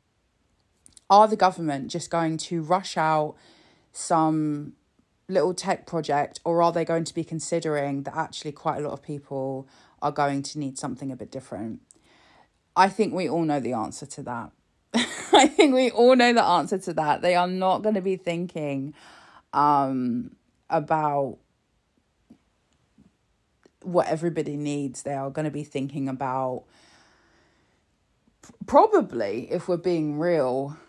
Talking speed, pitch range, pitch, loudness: 150 wpm, 140-175 Hz, 155 Hz, -24 LUFS